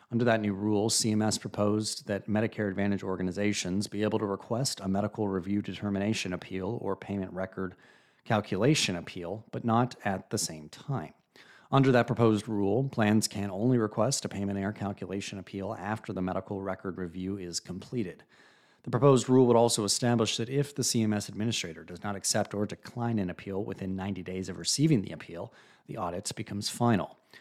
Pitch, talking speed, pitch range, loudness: 105 Hz, 175 wpm, 95-115 Hz, -30 LUFS